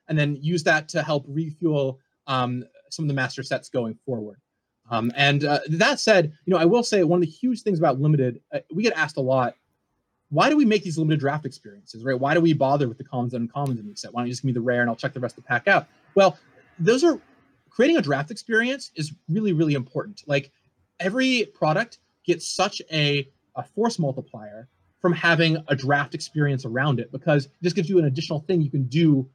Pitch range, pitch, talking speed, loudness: 130-175 Hz, 145 Hz, 230 wpm, -23 LUFS